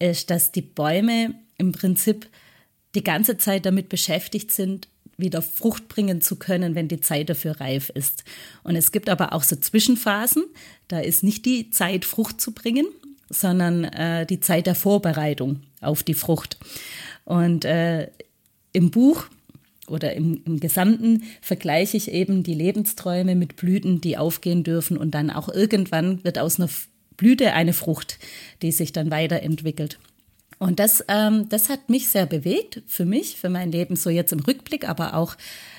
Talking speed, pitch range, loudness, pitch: 165 wpm, 160-205 Hz, -22 LUFS, 180 Hz